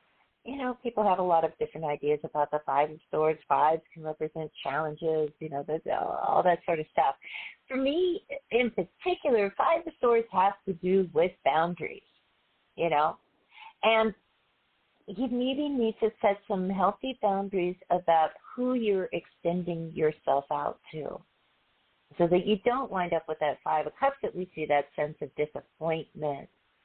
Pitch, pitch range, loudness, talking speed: 180 Hz, 155-230 Hz, -29 LUFS, 165 wpm